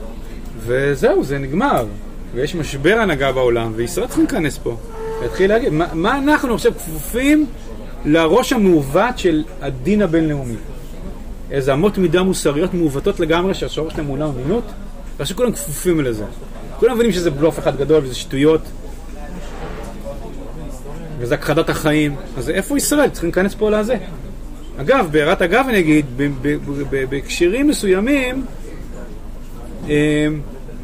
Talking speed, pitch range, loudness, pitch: 125 wpm, 140-210 Hz, -17 LUFS, 160 Hz